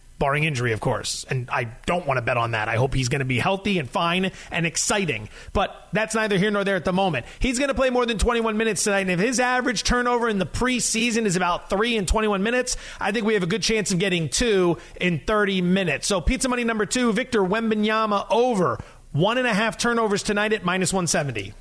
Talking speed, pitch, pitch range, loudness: 235 wpm, 200 Hz, 170-225 Hz, -22 LUFS